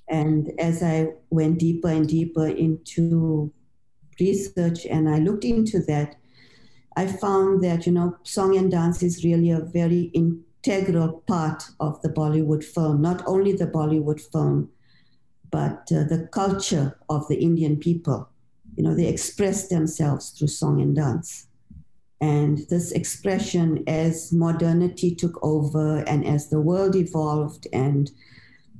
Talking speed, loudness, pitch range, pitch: 140 wpm, -23 LUFS, 150-175 Hz, 160 Hz